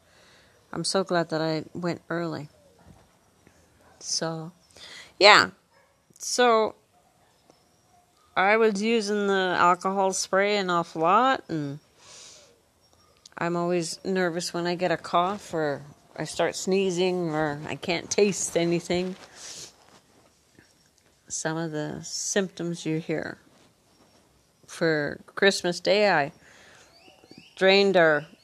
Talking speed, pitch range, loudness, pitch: 105 wpm, 165-195 Hz, -24 LUFS, 175 Hz